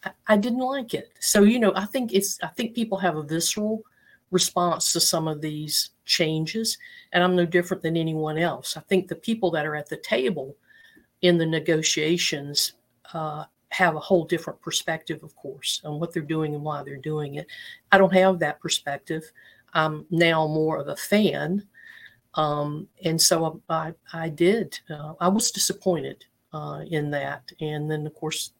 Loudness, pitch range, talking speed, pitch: -24 LUFS, 155-195 Hz, 185 wpm, 170 Hz